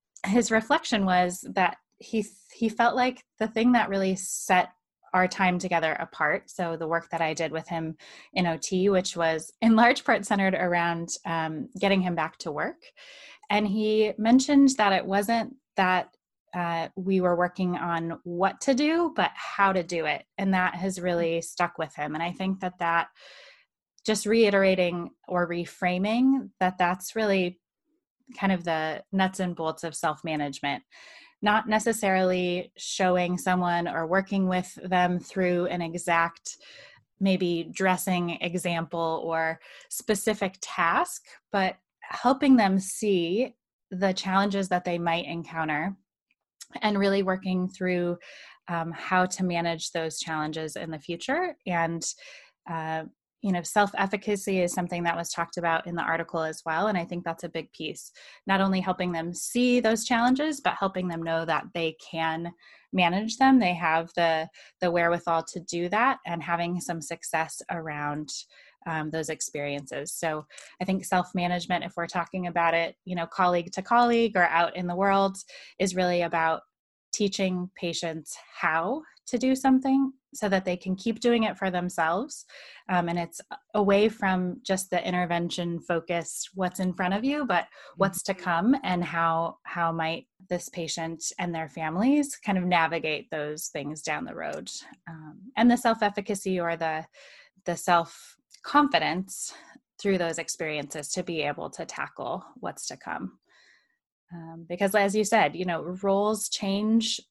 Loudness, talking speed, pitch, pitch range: -27 LUFS, 160 wpm, 180 Hz, 170-205 Hz